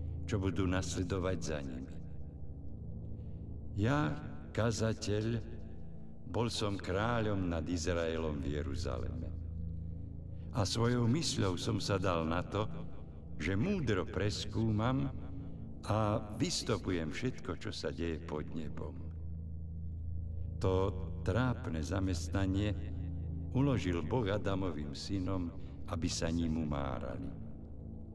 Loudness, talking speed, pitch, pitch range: -37 LUFS, 95 wpm, 85 Hz, 80-105 Hz